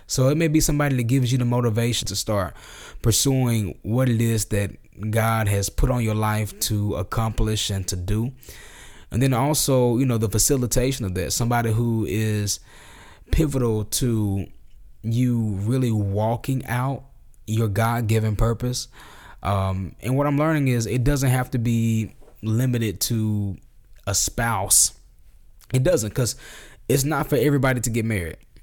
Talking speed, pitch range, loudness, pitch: 155 wpm, 105-125 Hz, -22 LUFS, 115 Hz